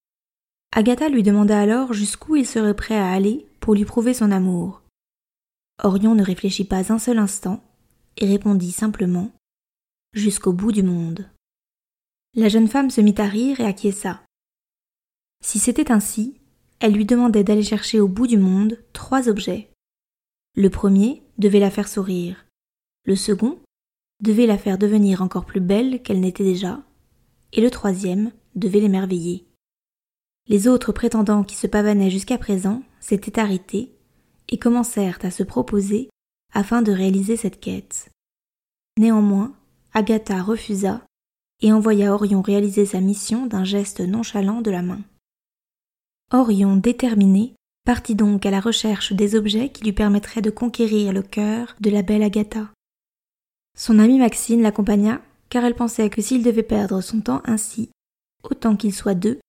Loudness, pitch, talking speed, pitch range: -19 LUFS, 210 Hz, 150 wpm, 200-230 Hz